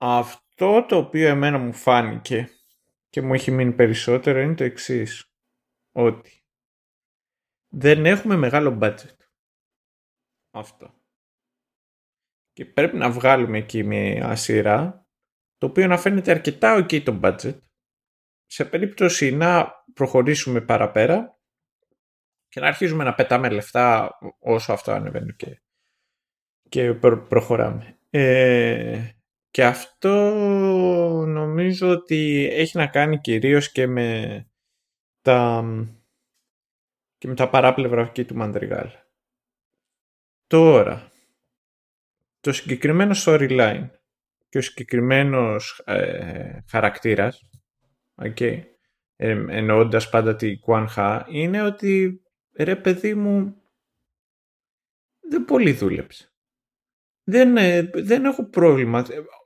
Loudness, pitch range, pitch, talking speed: -20 LUFS, 120-175 Hz, 135 Hz, 105 wpm